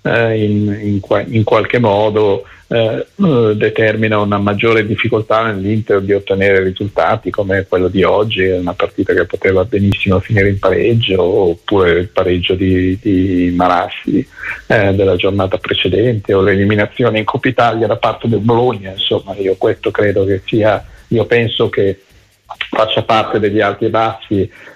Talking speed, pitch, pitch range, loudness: 150 wpm, 105 Hz, 95-110 Hz, -13 LUFS